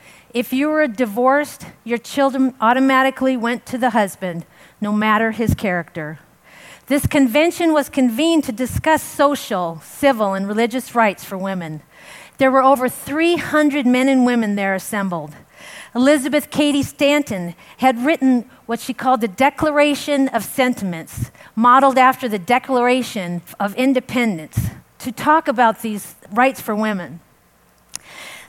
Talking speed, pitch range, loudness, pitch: 130 wpm, 200-275 Hz, -18 LUFS, 250 Hz